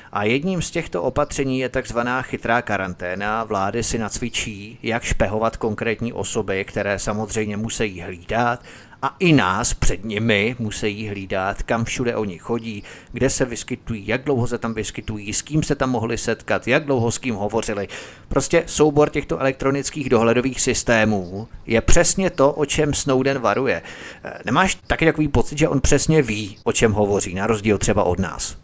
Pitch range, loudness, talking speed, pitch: 105-135 Hz, -21 LUFS, 165 wpm, 115 Hz